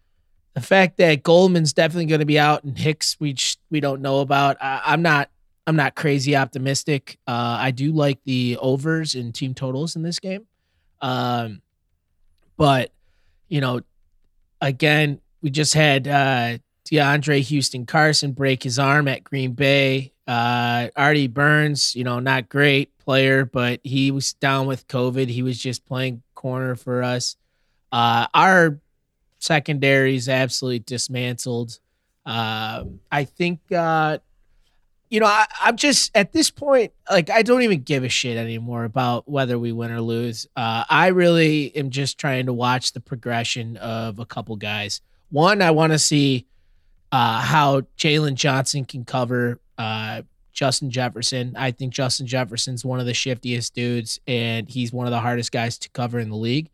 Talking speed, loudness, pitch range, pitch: 165 wpm, -20 LUFS, 120-145 Hz, 130 Hz